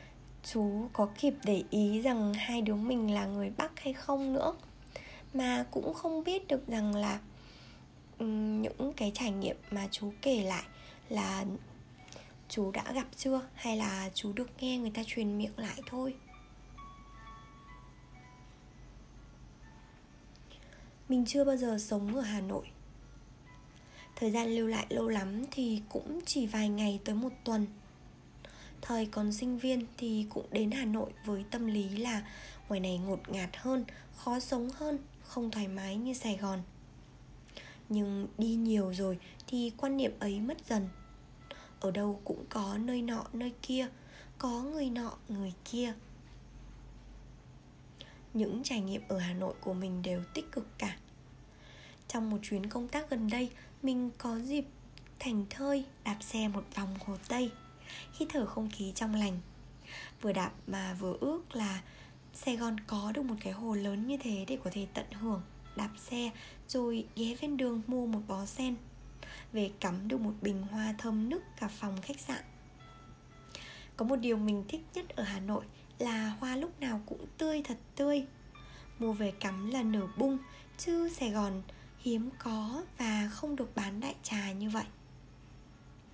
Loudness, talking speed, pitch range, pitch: -36 LUFS, 160 wpm, 200-250 Hz, 220 Hz